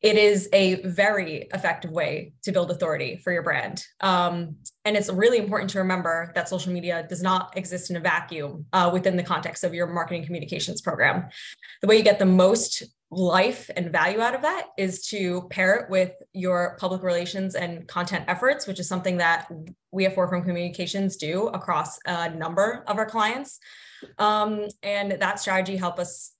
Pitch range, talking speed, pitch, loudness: 175-195 Hz, 185 wpm, 185 Hz, -24 LUFS